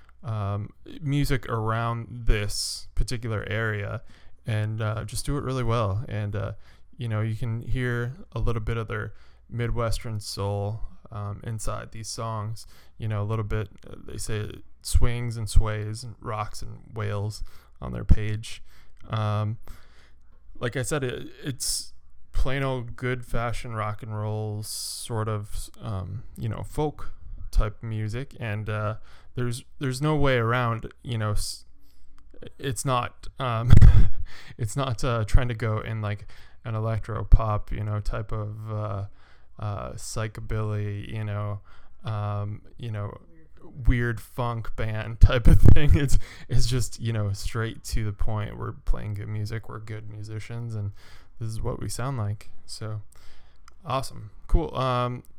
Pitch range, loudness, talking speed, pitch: 100-115 Hz, -29 LUFS, 150 wpm, 110 Hz